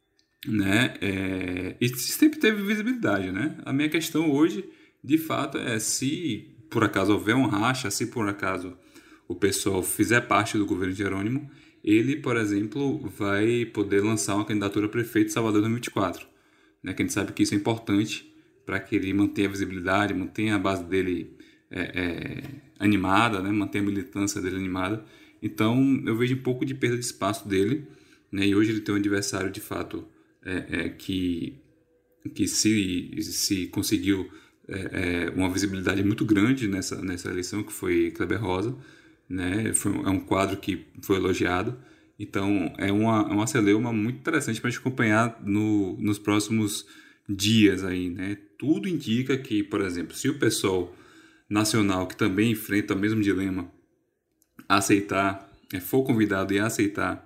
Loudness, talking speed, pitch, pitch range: -26 LUFS, 160 wpm, 105 Hz, 100-120 Hz